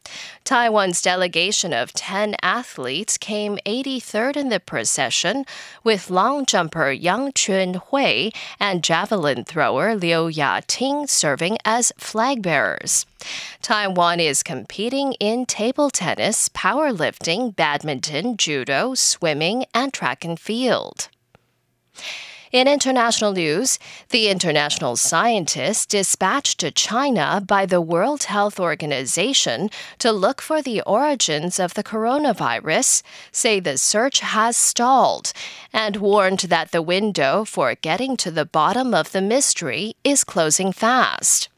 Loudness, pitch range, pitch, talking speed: -19 LUFS, 170-240 Hz, 205 Hz, 120 wpm